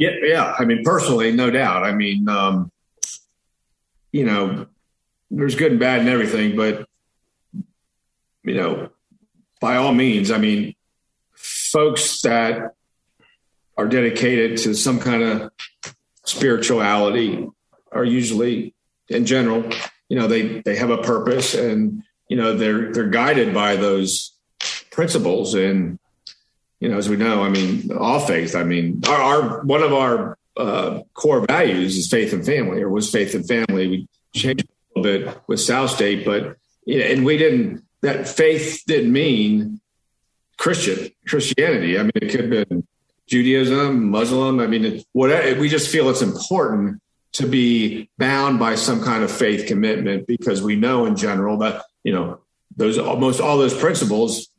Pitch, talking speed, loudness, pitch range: 120 Hz, 155 wpm, -19 LUFS, 105-150 Hz